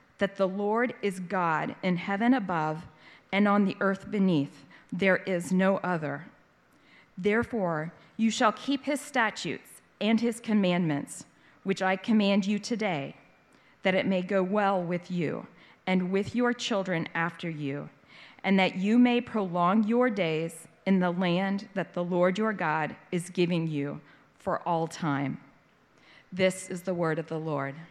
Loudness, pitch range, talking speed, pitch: -28 LUFS, 170-205 Hz, 155 wpm, 185 Hz